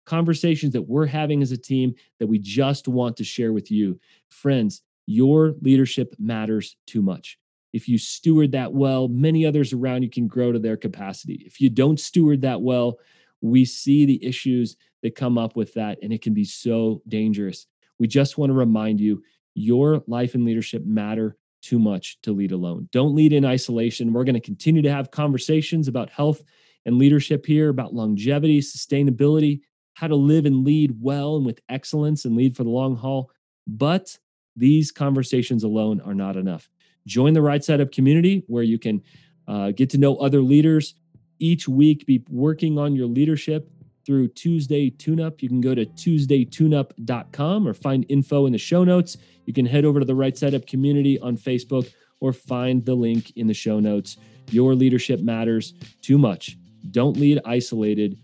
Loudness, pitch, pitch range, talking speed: -21 LUFS, 130 Hz, 115-145 Hz, 185 wpm